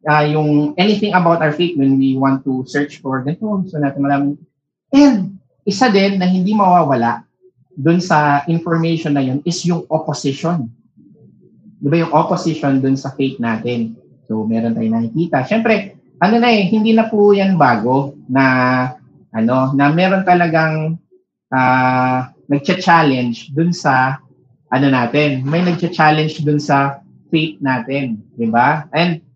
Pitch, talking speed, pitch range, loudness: 150 Hz, 145 wpm, 130-175 Hz, -15 LUFS